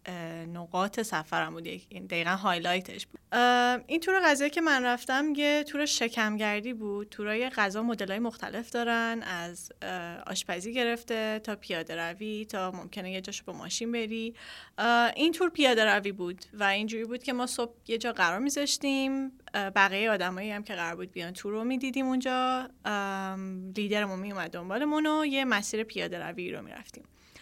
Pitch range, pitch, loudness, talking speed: 190-250 Hz, 215 Hz, -30 LUFS, 155 wpm